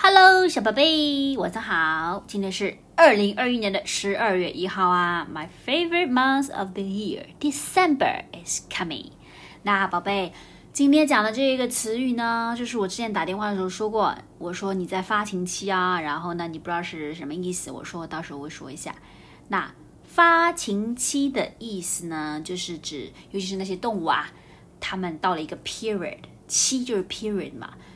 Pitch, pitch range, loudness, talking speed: 200 Hz, 180-250 Hz, -23 LUFS, 345 characters per minute